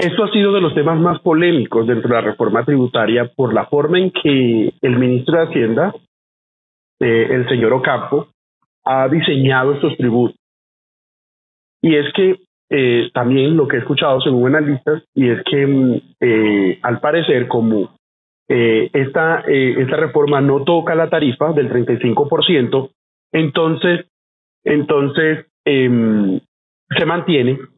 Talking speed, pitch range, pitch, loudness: 140 wpm, 120-160 Hz, 135 Hz, -15 LUFS